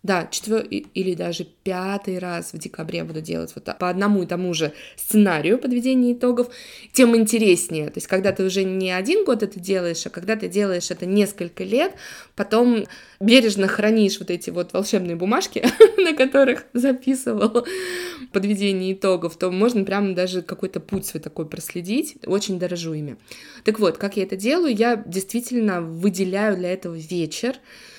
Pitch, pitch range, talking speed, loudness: 195 Hz, 180-235 Hz, 165 wpm, -21 LUFS